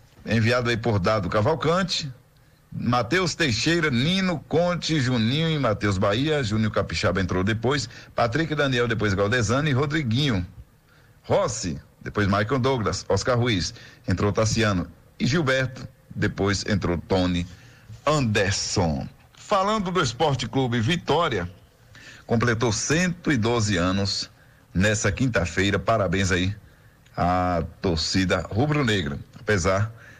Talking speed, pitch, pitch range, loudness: 105 wpm, 115 Hz, 100-135 Hz, -23 LUFS